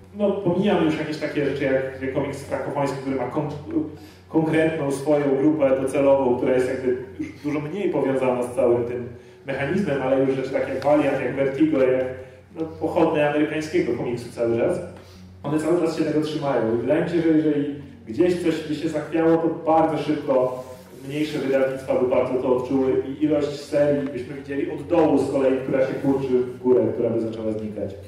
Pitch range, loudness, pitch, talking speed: 130-155 Hz, -22 LUFS, 140 Hz, 180 wpm